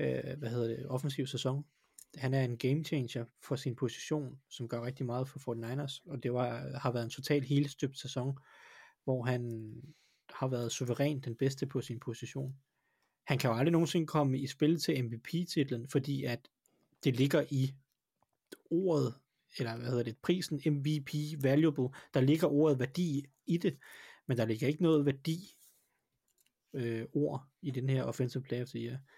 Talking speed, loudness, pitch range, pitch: 165 wpm, -35 LUFS, 125-145 Hz, 135 Hz